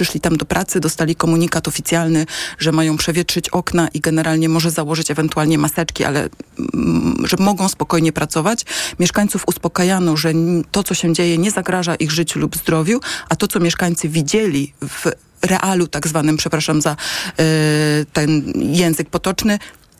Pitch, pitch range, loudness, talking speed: 165 Hz, 160-180 Hz, -17 LUFS, 150 wpm